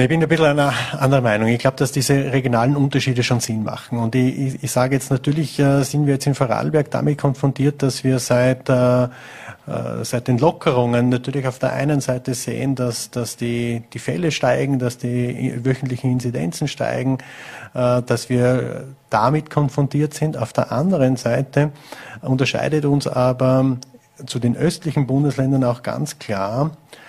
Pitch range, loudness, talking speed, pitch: 125-145 Hz, -19 LUFS, 155 wpm, 130 Hz